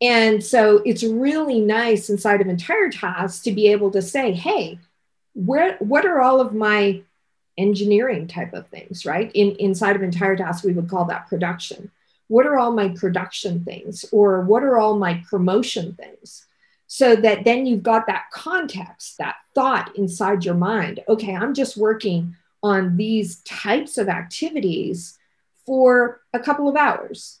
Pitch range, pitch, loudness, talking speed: 195-240 Hz, 210 Hz, -19 LUFS, 165 wpm